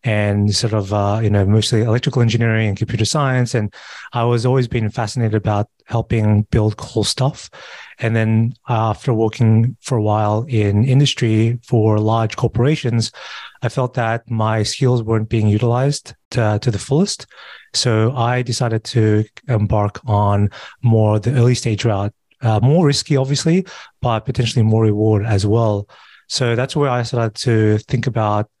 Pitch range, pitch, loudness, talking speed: 110-125 Hz, 115 Hz, -17 LUFS, 165 wpm